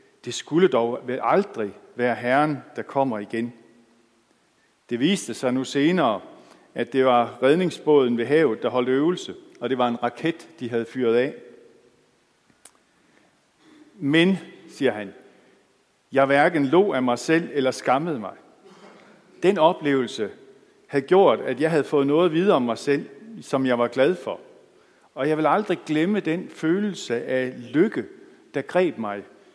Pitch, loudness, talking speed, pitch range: 140 Hz, -23 LUFS, 150 wpm, 120-170 Hz